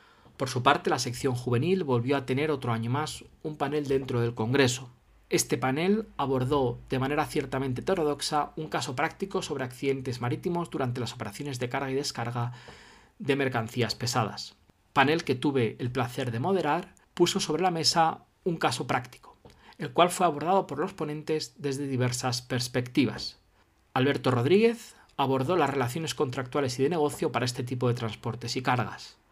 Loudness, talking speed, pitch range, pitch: -28 LUFS, 165 wpm, 125-155 Hz, 135 Hz